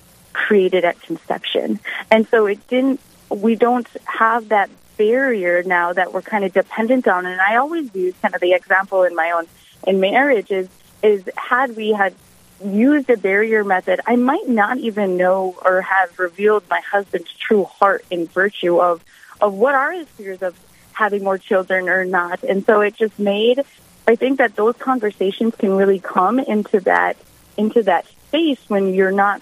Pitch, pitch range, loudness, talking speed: 200 Hz, 185-230 Hz, -17 LUFS, 180 wpm